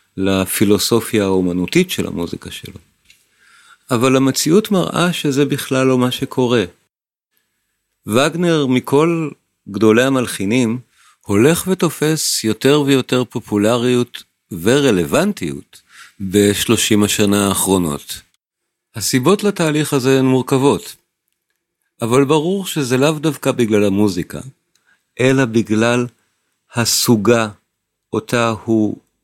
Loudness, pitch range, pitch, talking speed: -16 LUFS, 105-140 Hz, 125 Hz, 90 wpm